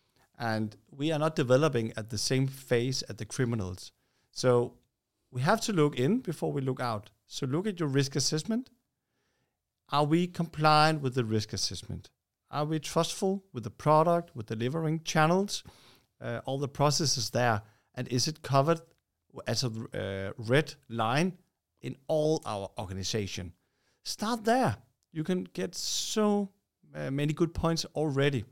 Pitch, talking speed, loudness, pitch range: 135 Hz, 155 wpm, -30 LUFS, 115-160 Hz